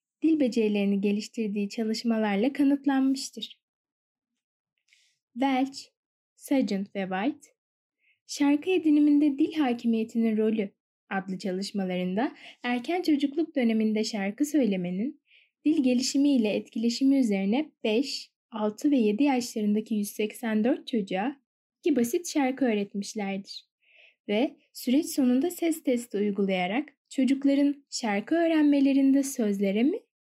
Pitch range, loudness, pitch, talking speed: 215-285 Hz, -27 LUFS, 250 Hz, 95 wpm